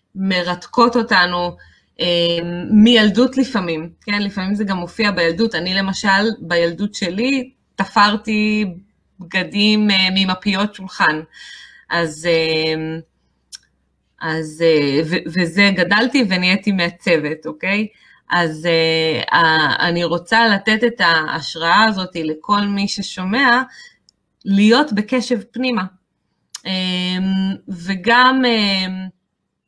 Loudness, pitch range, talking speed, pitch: -16 LUFS, 170-215 Hz, 80 wpm, 190 Hz